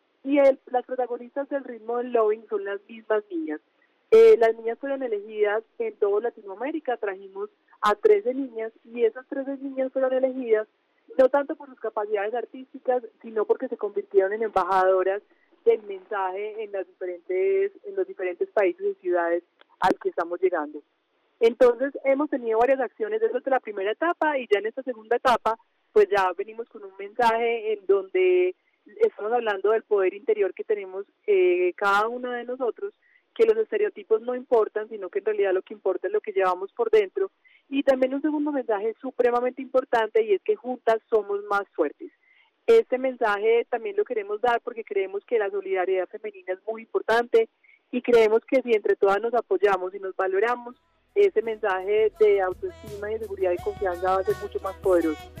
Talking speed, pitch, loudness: 180 wpm, 245 Hz, -25 LUFS